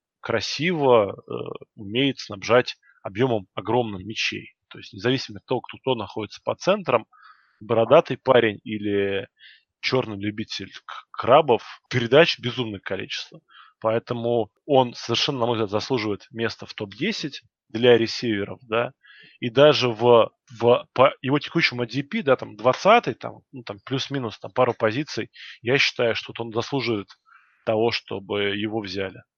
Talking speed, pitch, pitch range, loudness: 135 wpm, 115 Hz, 105-130 Hz, -23 LUFS